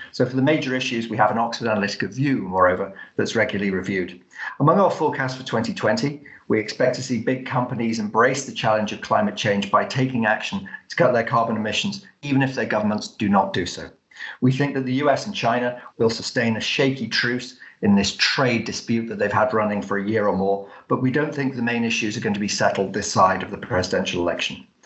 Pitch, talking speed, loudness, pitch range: 115 Hz, 220 wpm, -22 LUFS, 105-130 Hz